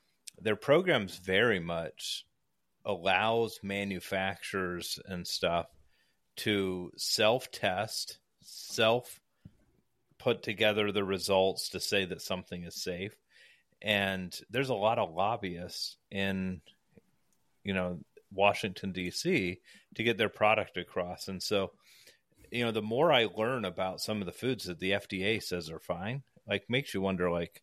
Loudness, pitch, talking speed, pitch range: -32 LUFS, 95 Hz, 135 wpm, 90-105 Hz